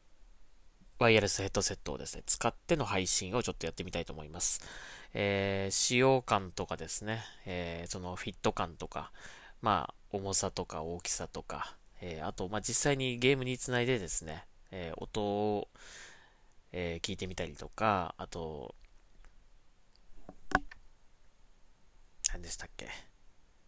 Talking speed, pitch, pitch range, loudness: 280 characters per minute, 95 Hz, 85-105 Hz, -33 LUFS